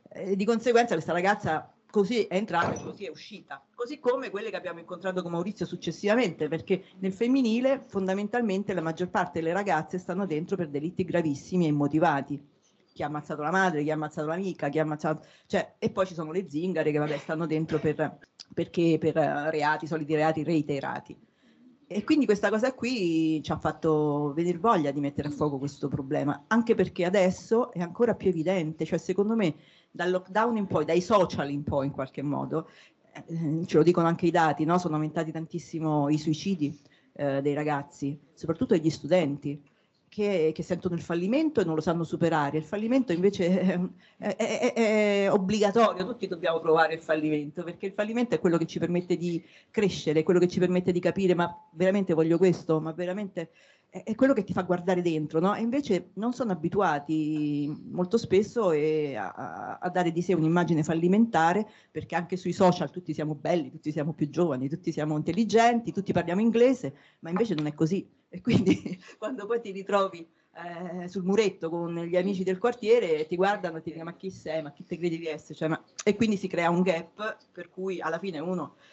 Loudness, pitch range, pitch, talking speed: -28 LUFS, 155-195 Hz, 175 Hz, 195 wpm